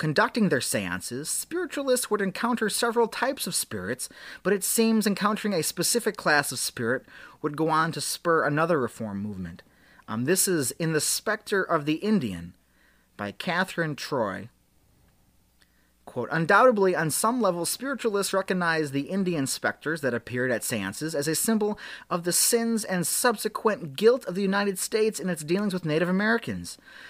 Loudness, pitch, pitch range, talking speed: -26 LUFS, 180 Hz, 150-215 Hz, 160 wpm